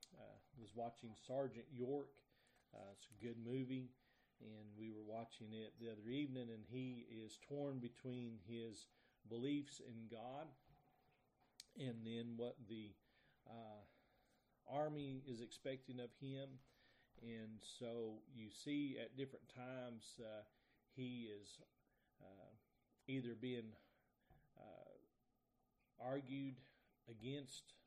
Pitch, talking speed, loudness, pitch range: 120 Hz, 115 wpm, -52 LUFS, 115-130 Hz